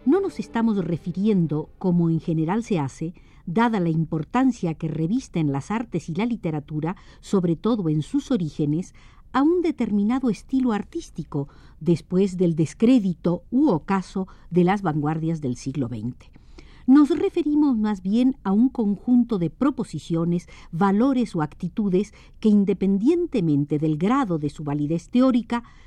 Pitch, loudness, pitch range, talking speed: 190 Hz, -23 LUFS, 160-235 Hz, 140 wpm